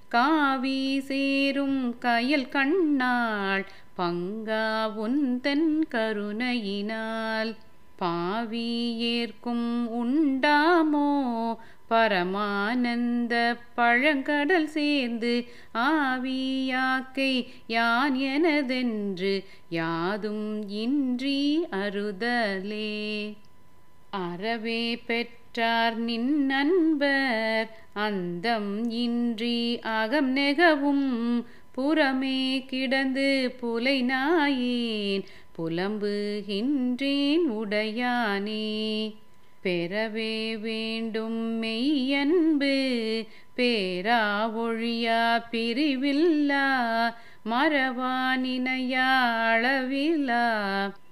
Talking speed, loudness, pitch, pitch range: 45 wpm, -26 LUFS, 235 Hz, 220-270 Hz